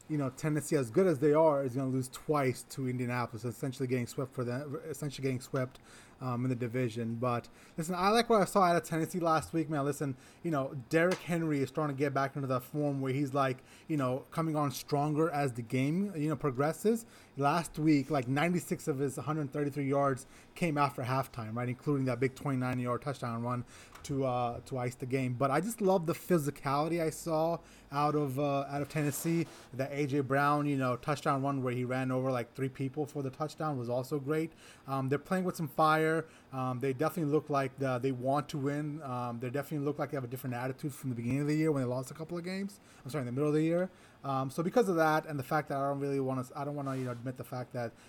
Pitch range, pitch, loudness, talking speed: 130-155 Hz, 140 Hz, -33 LUFS, 245 wpm